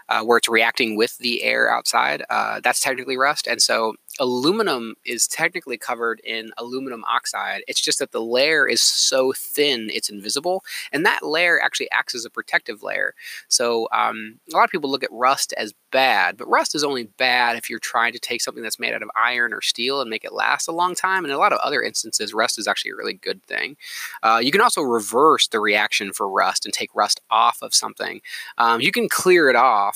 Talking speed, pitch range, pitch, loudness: 220 wpm, 115-145 Hz, 125 Hz, -20 LUFS